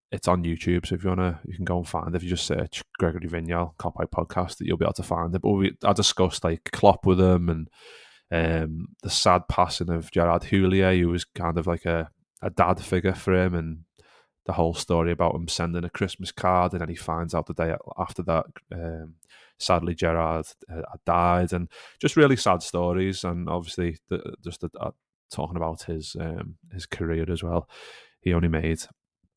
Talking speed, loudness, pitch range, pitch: 210 wpm, -25 LUFS, 85-90 Hz, 85 Hz